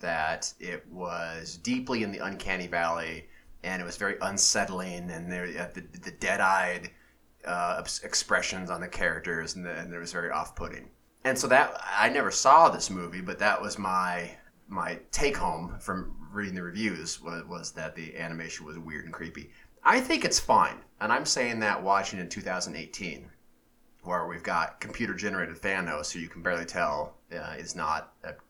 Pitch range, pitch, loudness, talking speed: 85-95 Hz, 90 Hz, -29 LUFS, 175 wpm